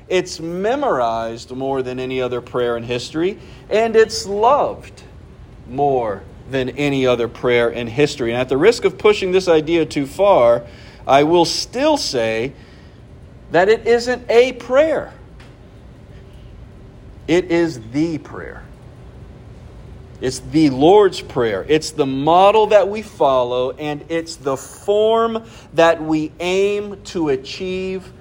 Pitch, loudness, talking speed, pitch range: 150 Hz, -17 LUFS, 130 wpm, 125-195 Hz